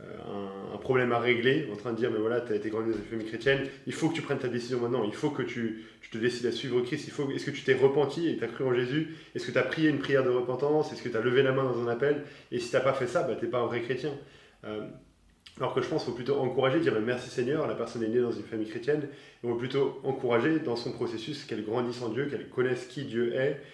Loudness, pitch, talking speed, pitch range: -30 LUFS, 125 Hz, 300 wpm, 115-140 Hz